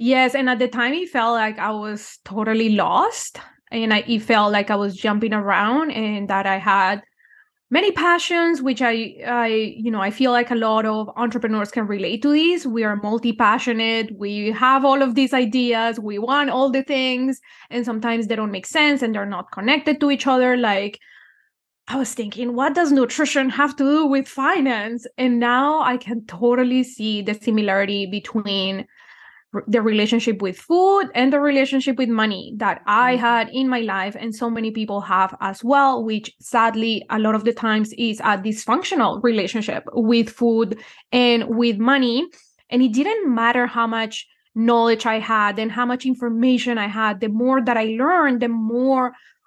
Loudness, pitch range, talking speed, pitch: -19 LUFS, 215-260 Hz, 185 wpm, 235 Hz